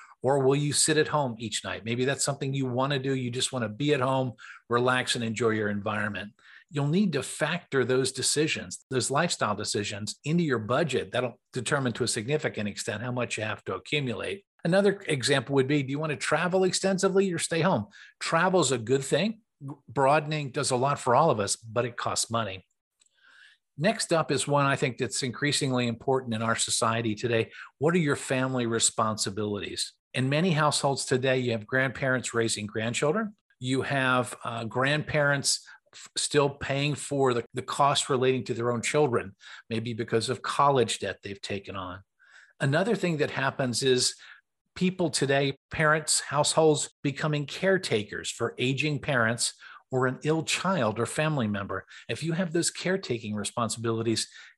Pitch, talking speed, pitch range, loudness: 130 Hz, 175 wpm, 115-150 Hz, -27 LUFS